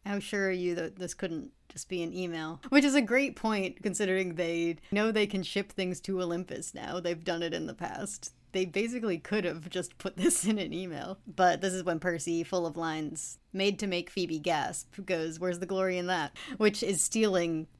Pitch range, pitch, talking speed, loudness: 170-200 Hz, 185 Hz, 215 wpm, -31 LUFS